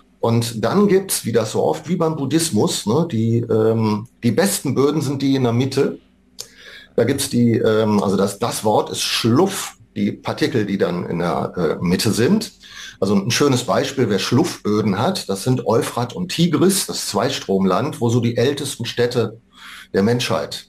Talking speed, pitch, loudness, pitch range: 180 wpm, 120 Hz, -19 LUFS, 110-145 Hz